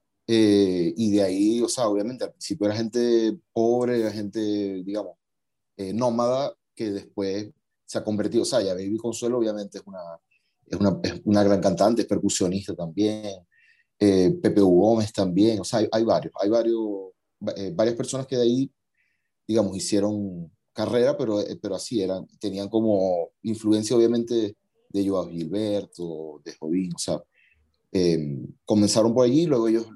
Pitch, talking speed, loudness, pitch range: 105 Hz, 160 wpm, -24 LUFS, 95-115 Hz